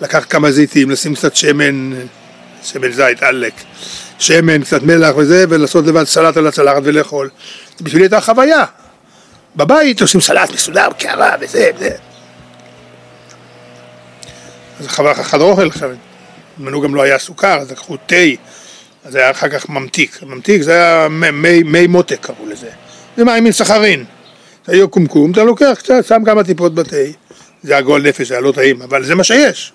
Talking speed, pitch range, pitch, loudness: 170 wpm, 130-190 Hz, 155 Hz, -10 LUFS